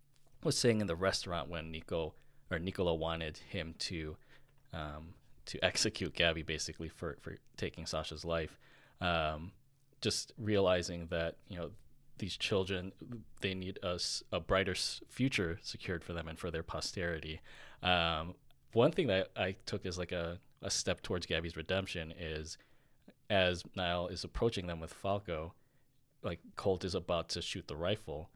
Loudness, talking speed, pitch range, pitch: -37 LUFS, 155 wpm, 80-100 Hz, 90 Hz